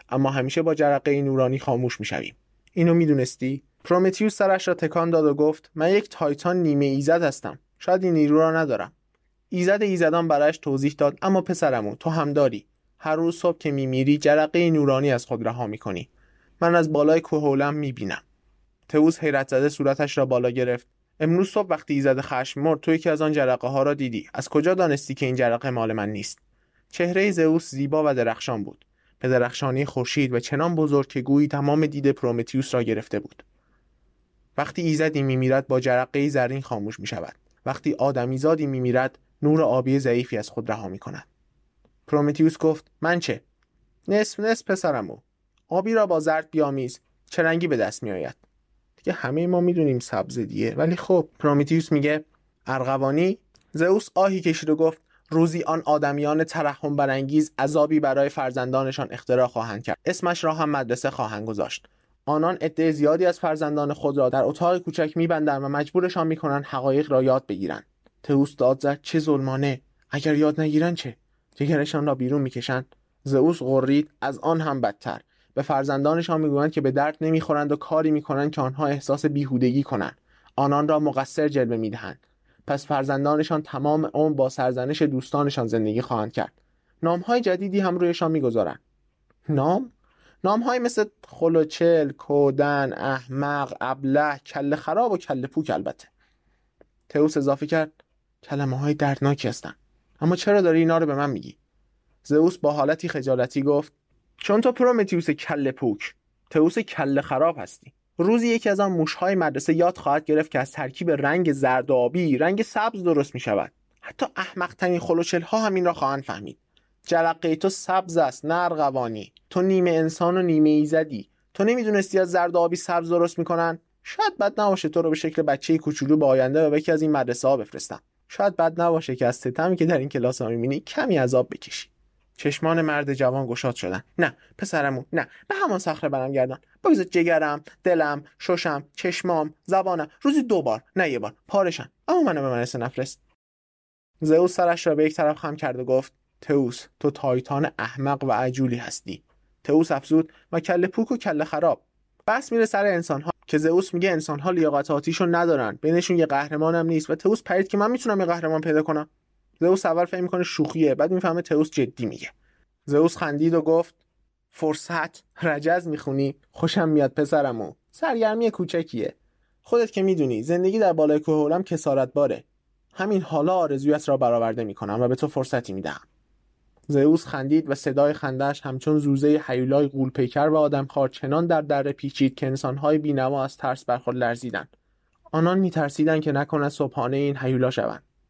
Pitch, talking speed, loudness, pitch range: 150 Hz, 170 wpm, -23 LUFS, 135-165 Hz